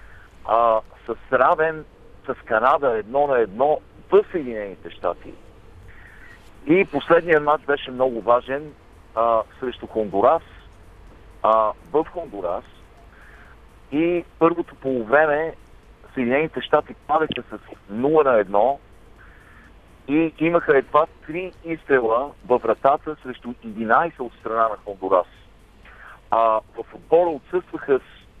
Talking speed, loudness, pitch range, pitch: 105 wpm, -21 LUFS, 110-160 Hz, 130 Hz